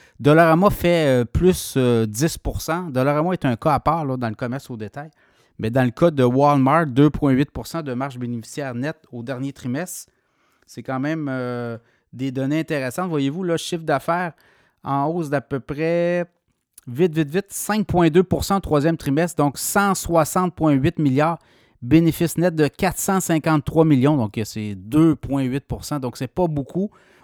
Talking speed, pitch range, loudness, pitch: 155 wpm, 130-165 Hz, -20 LUFS, 150 Hz